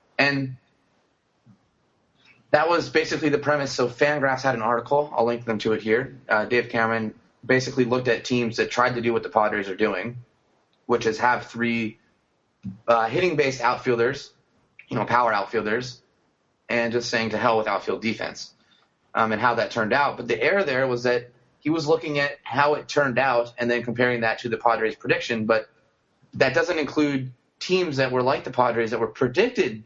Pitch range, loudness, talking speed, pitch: 115-140 Hz, -23 LUFS, 185 wpm, 125 Hz